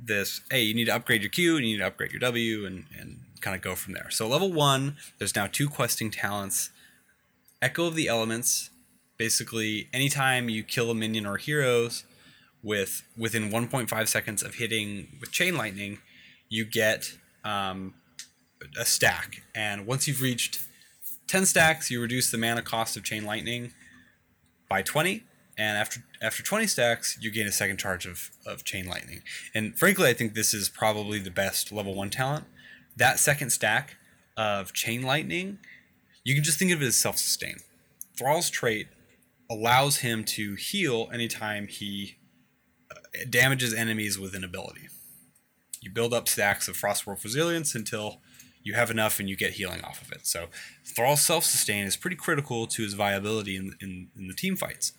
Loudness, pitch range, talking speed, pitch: -27 LUFS, 100-125 Hz, 175 wpm, 110 Hz